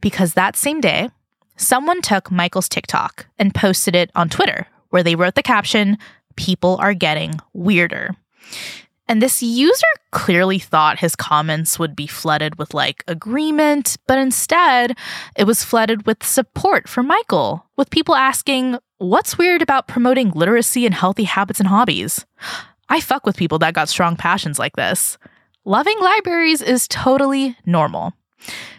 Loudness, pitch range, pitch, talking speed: -16 LUFS, 175-260 Hz, 210 Hz, 150 wpm